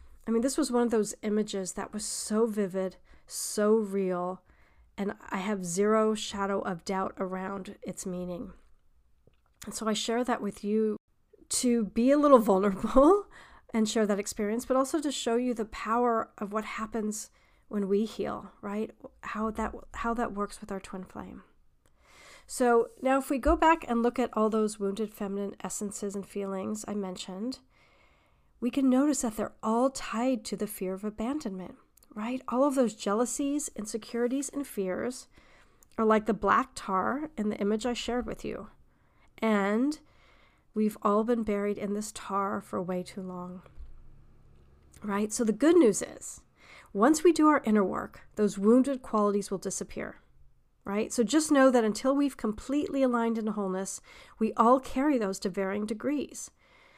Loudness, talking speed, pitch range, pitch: -29 LUFS, 170 wpm, 200-245 Hz, 215 Hz